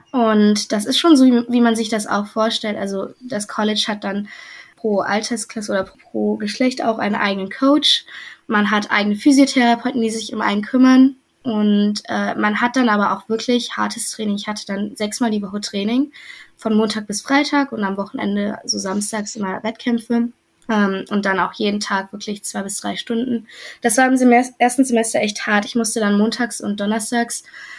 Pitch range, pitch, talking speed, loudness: 205-240 Hz, 220 Hz, 190 wpm, -18 LUFS